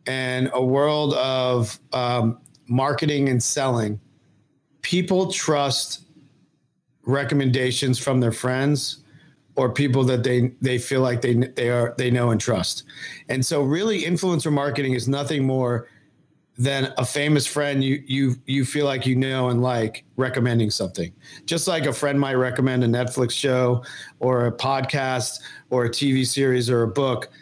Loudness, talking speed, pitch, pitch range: -22 LUFS, 155 wpm, 130 Hz, 125-145 Hz